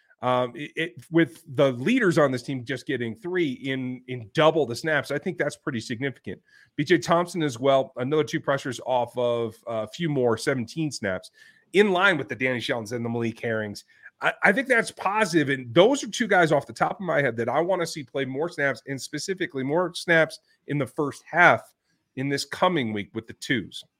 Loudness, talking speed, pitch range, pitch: -25 LUFS, 215 wpm, 125-165 Hz, 140 Hz